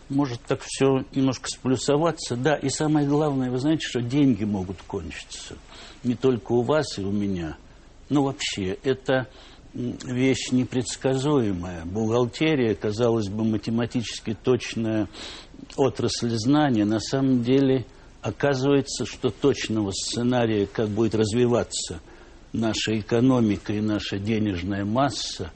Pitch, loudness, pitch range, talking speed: 120 Hz, -24 LUFS, 105-135 Hz, 115 wpm